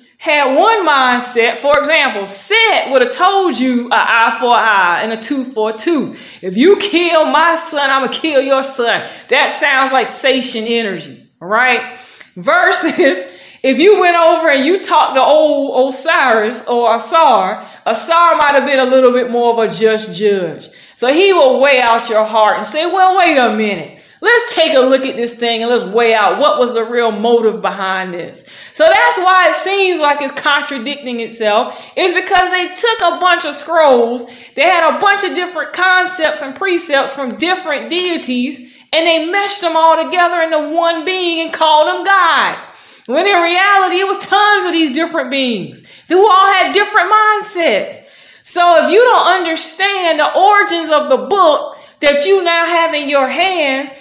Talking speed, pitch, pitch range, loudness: 185 wpm, 300 Hz, 250-355 Hz, -12 LUFS